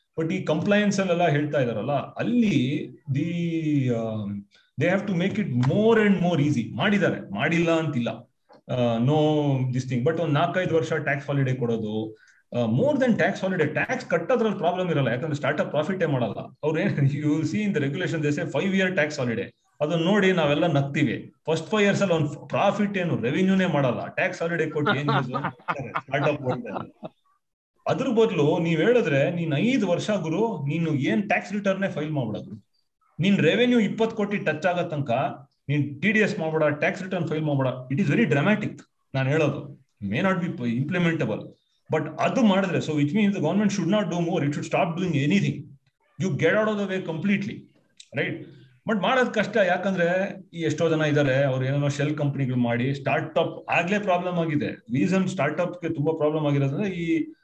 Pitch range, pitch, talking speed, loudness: 145-190 Hz, 160 Hz, 145 wpm, -24 LUFS